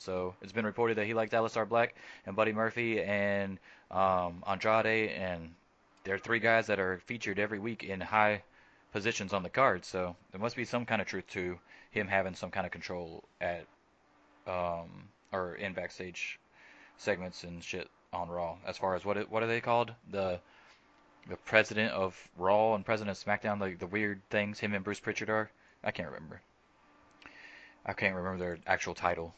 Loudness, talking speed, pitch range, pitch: -33 LUFS, 185 wpm, 90-110 Hz, 100 Hz